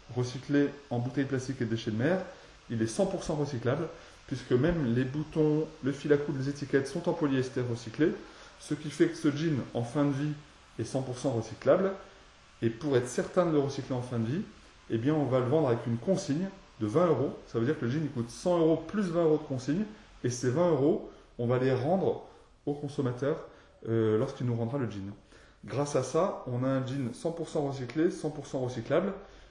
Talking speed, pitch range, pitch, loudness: 210 wpm, 125-155 Hz, 140 Hz, -31 LUFS